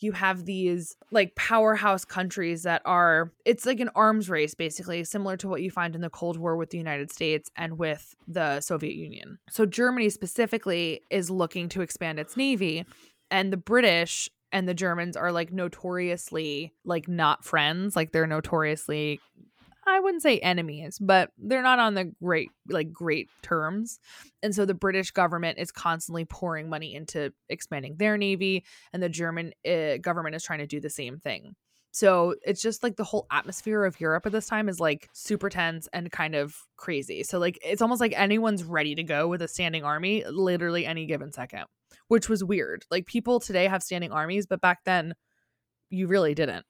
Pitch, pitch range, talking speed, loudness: 175 Hz, 160-200 Hz, 190 wpm, -27 LUFS